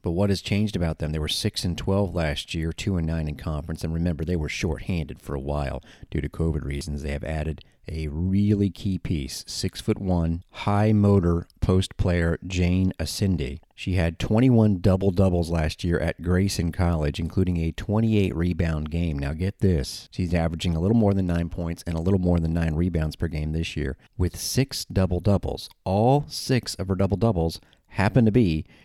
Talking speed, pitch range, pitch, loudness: 195 wpm, 80-100 Hz, 90 Hz, -25 LUFS